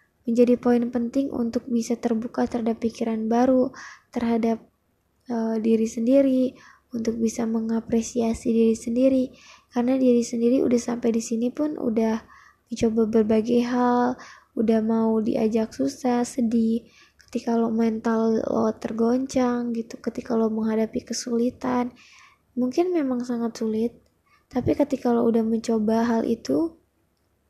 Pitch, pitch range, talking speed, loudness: 235 Hz, 230-250 Hz, 120 wpm, -24 LUFS